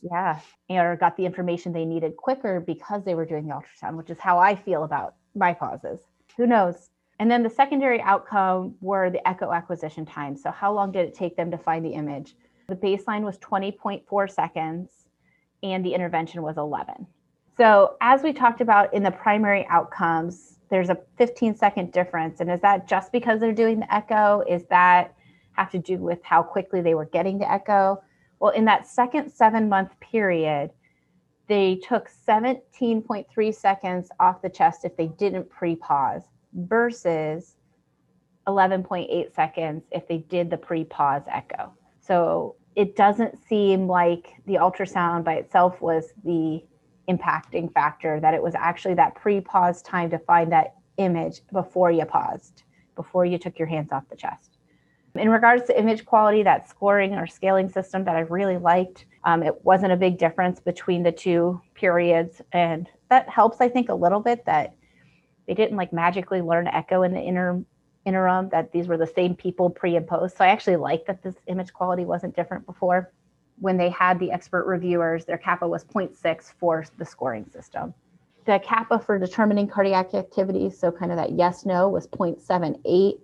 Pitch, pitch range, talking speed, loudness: 185 Hz, 170-200 Hz, 180 wpm, -23 LUFS